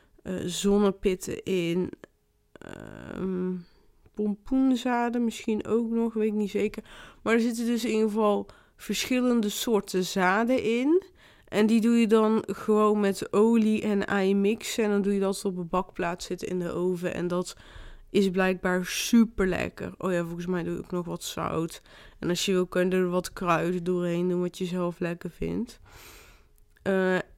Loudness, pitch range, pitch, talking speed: -27 LUFS, 180-220 Hz, 195 Hz, 170 wpm